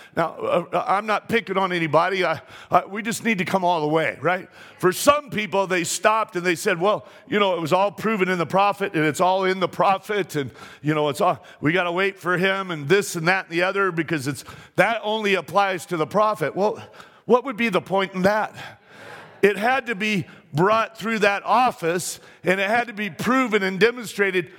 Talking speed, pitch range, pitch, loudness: 220 wpm, 175-210 Hz, 190 Hz, -22 LUFS